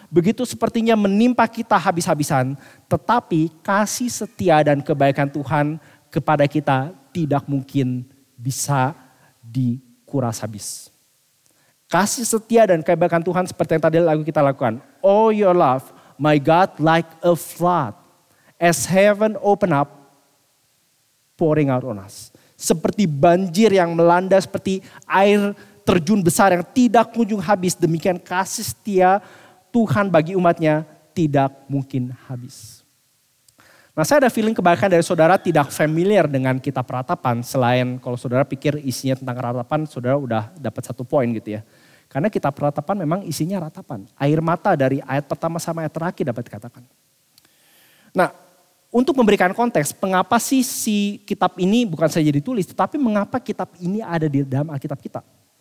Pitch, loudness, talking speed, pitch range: 160 Hz, -19 LUFS, 140 wpm, 135-190 Hz